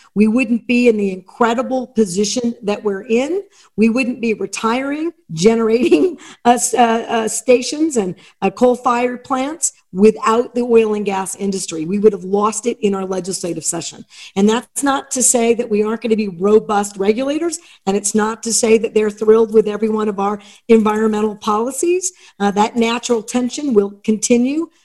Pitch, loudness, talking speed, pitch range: 225 Hz, -16 LUFS, 175 wpm, 210-245 Hz